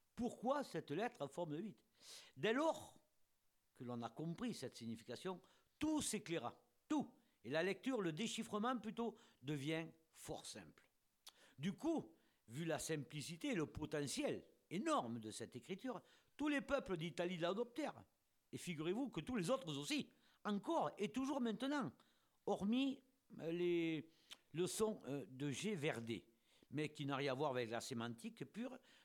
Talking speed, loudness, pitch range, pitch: 145 wpm, -45 LUFS, 140-235 Hz, 170 Hz